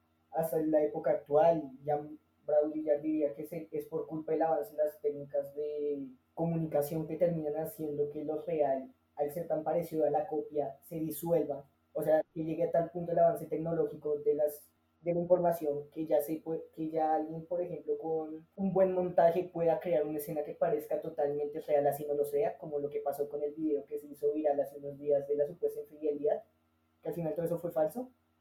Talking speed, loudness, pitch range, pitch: 210 wpm, -33 LUFS, 145-160 Hz, 150 Hz